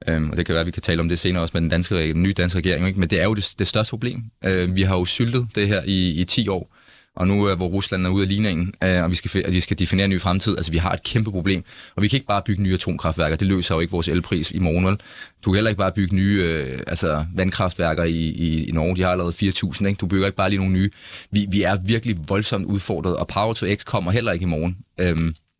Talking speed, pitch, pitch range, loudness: 270 wpm, 95 Hz, 85-100 Hz, -21 LUFS